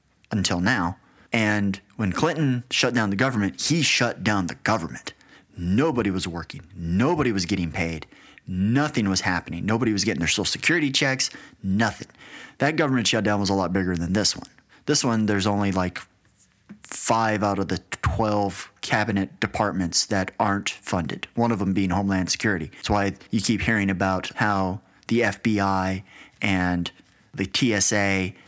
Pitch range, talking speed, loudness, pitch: 95-115 Hz, 160 wpm, -23 LUFS, 100 Hz